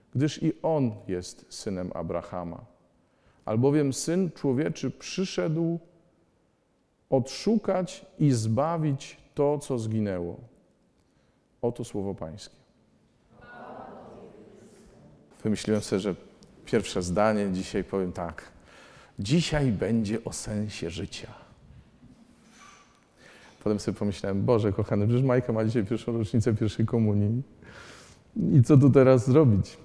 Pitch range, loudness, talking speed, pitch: 100-140 Hz, -27 LUFS, 100 wpm, 115 Hz